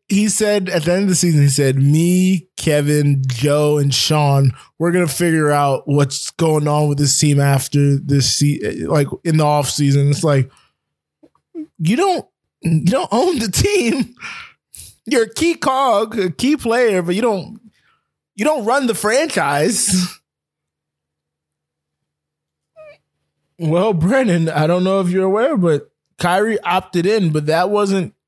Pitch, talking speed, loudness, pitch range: 175 Hz, 155 wpm, -16 LUFS, 145-210 Hz